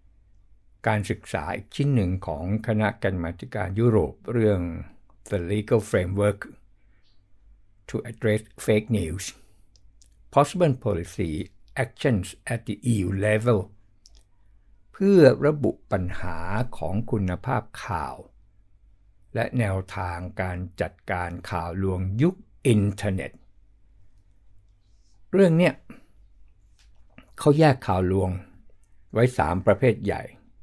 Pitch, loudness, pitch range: 100 Hz, -25 LUFS, 95-110 Hz